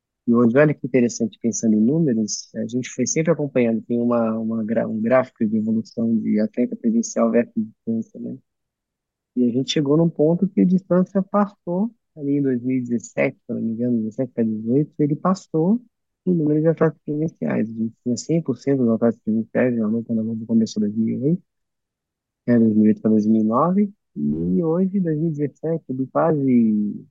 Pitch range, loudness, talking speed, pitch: 115-170 Hz, -21 LUFS, 175 wpm, 130 Hz